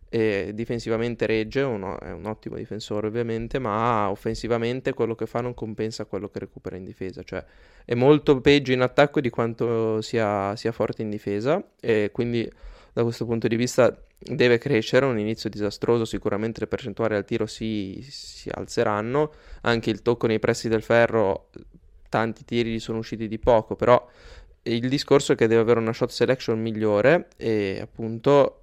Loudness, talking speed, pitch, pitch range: -24 LUFS, 165 wpm, 115 Hz, 110-120 Hz